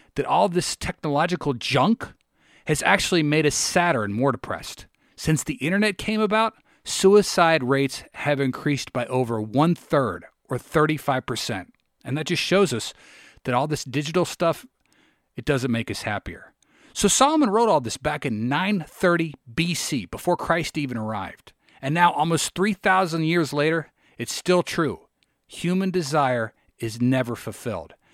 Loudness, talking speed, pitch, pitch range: -23 LUFS, 150 wpm, 150 Hz, 125-175 Hz